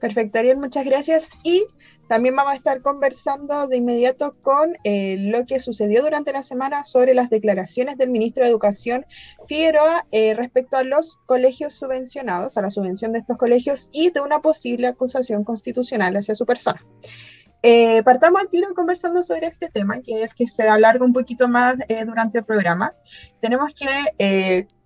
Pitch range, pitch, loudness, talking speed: 225-285 Hz, 250 Hz, -19 LUFS, 175 wpm